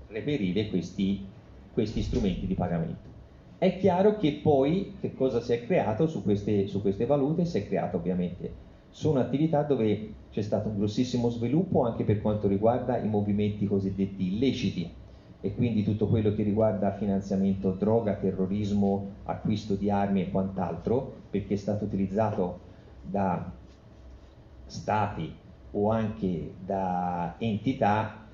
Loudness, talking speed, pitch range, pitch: -28 LUFS, 135 wpm, 95-115 Hz, 105 Hz